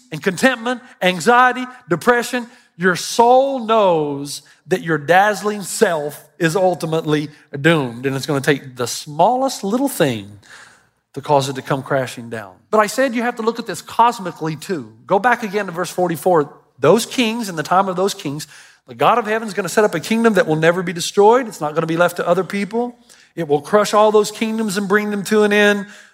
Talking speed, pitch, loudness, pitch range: 205 wpm, 190 Hz, -17 LUFS, 155-225 Hz